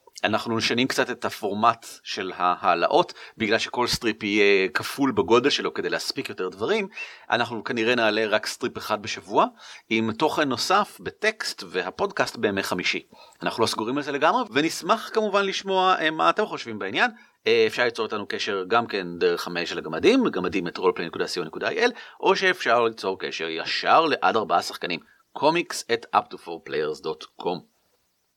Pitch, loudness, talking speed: 185 Hz, -24 LUFS, 145 wpm